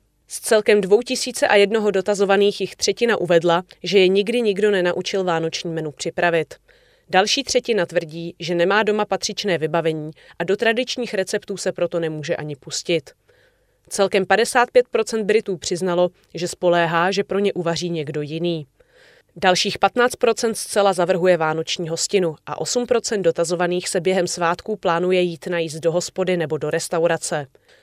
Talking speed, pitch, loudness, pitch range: 140 wpm, 185 Hz, -20 LUFS, 170-210 Hz